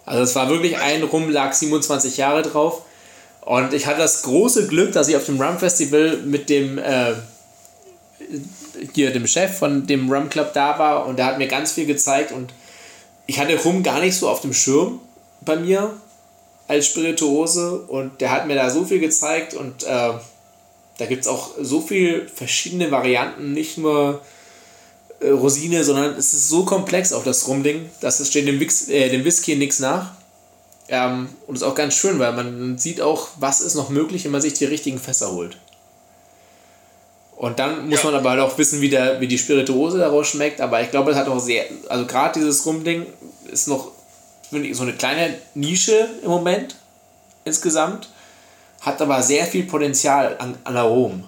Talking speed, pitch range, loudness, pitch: 185 wpm, 135-165 Hz, -19 LUFS, 145 Hz